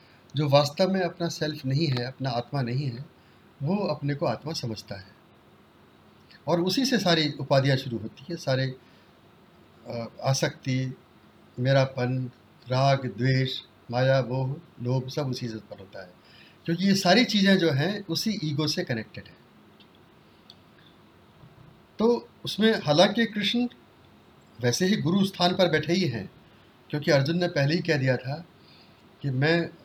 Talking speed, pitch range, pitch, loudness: 145 wpm, 130-175 Hz, 145 Hz, -26 LUFS